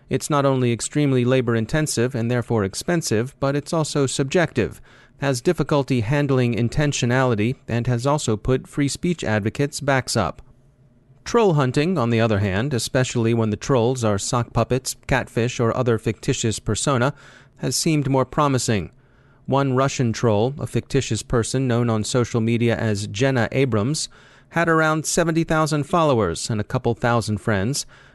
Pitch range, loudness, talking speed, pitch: 115-140 Hz, -21 LUFS, 150 wpm, 125 Hz